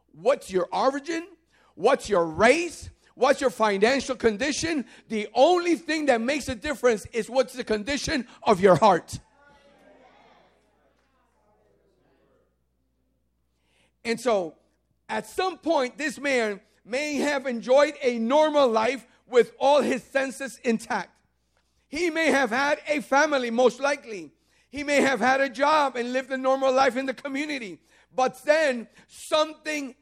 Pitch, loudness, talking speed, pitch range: 265 Hz, -24 LUFS, 135 wpm, 230-285 Hz